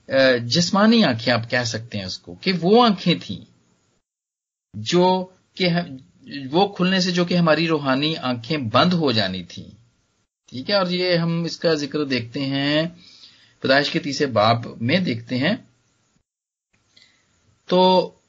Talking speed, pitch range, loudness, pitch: 140 wpm, 120-175 Hz, -20 LUFS, 145 Hz